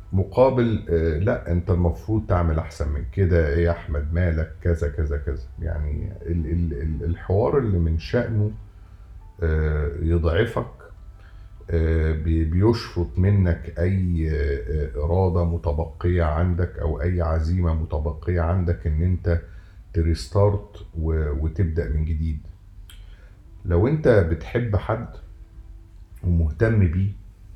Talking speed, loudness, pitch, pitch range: 95 wpm, -23 LUFS, 85 Hz, 80-95 Hz